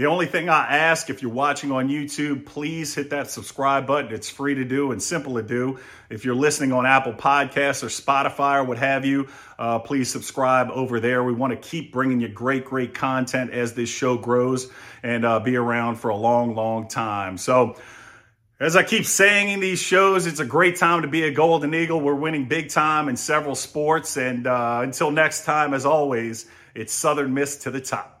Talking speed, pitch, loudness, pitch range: 210 wpm, 135 Hz, -21 LUFS, 120-150 Hz